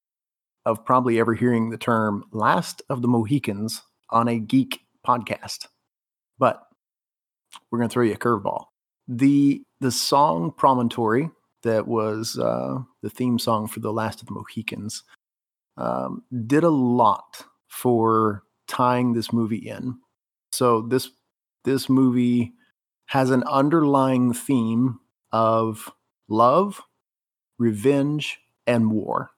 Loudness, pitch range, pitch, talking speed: -22 LUFS, 110-130 Hz, 120 Hz, 125 wpm